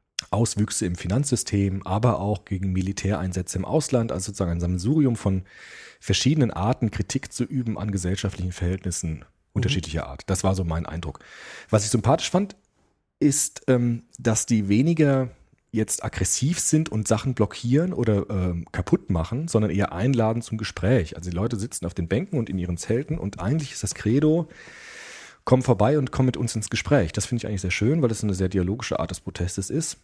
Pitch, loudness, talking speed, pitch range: 110 Hz, -24 LUFS, 180 wpm, 95-130 Hz